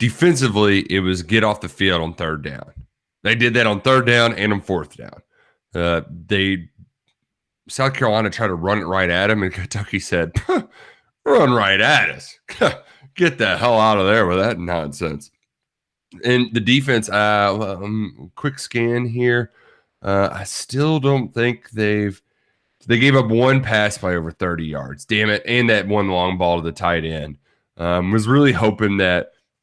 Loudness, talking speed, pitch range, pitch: -18 LUFS, 180 wpm, 90-120 Hz, 105 Hz